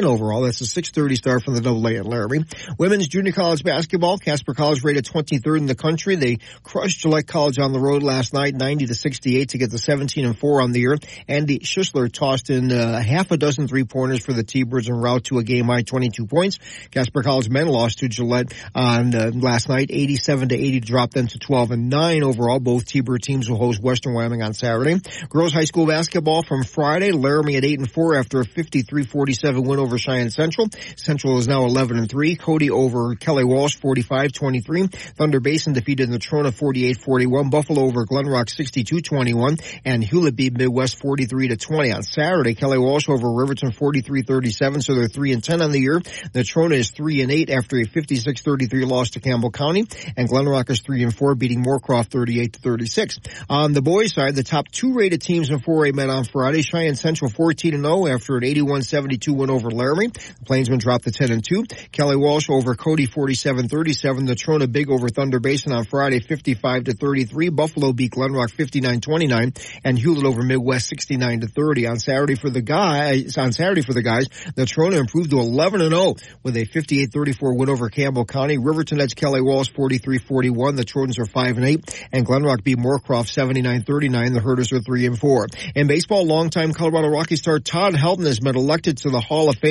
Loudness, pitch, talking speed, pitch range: -20 LUFS, 135 Hz, 195 wpm, 125-150 Hz